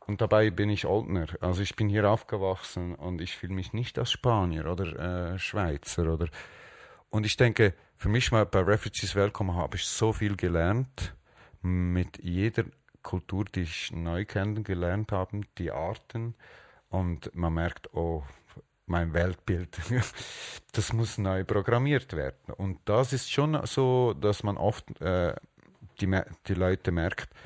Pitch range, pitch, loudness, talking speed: 90-110 Hz, 95 Hz, -29 LUFS, 155 wpm